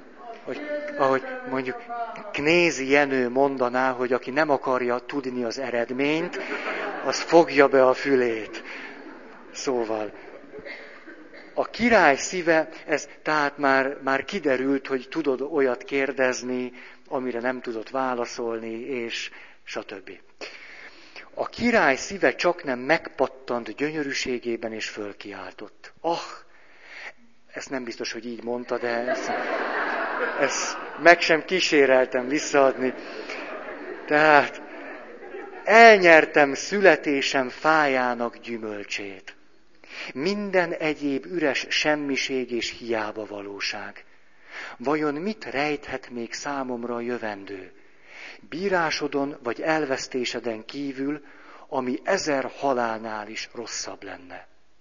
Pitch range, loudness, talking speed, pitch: 120-155 Hz, -23 LUFS, 100 wpm, 135 Hz